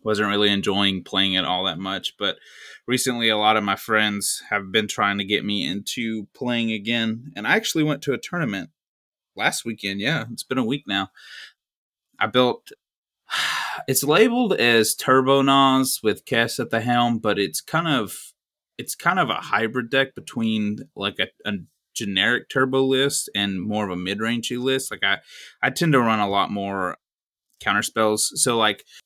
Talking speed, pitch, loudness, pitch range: 180 wpm, 110 Hz, -22 LUFS, 100-130 Hz